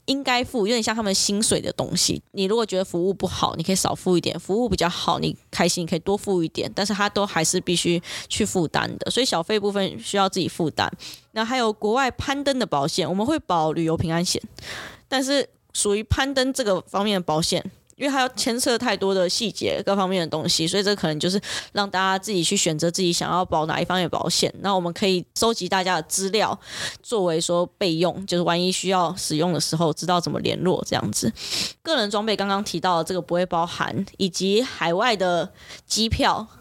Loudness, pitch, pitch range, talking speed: -23 LUFS, 185 Hz, 170-210 Hz, 330 characters per minute